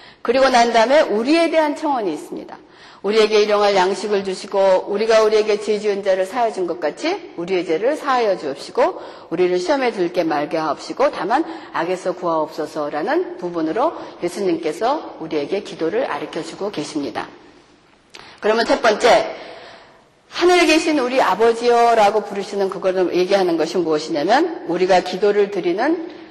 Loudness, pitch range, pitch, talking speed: -18 LUFS, 180-275 Hz, 205 Hz, 365 characters per minute